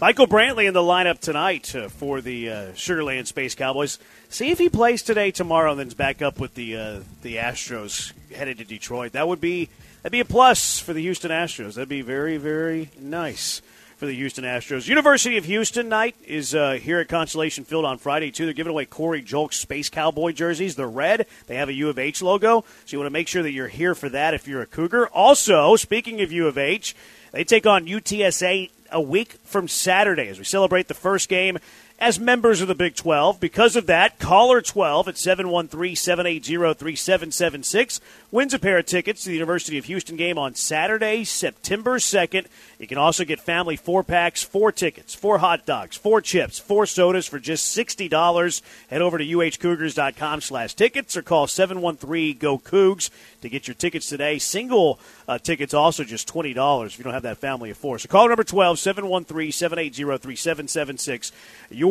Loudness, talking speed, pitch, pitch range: -21 LUFS, 215 wpm, 165 Hz, 145-190 Hz